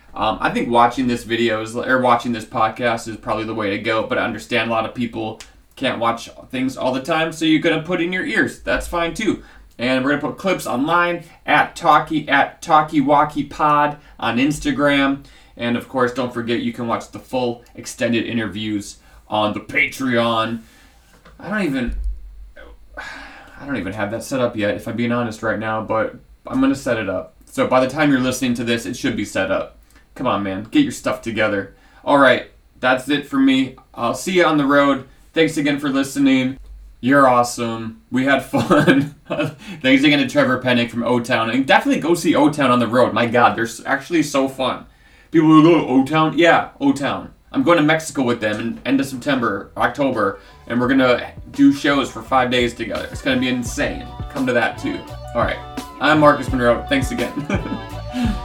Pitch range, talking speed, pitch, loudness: 115-155 Hz, 205 wpm, 130 Hz, -18 LUFS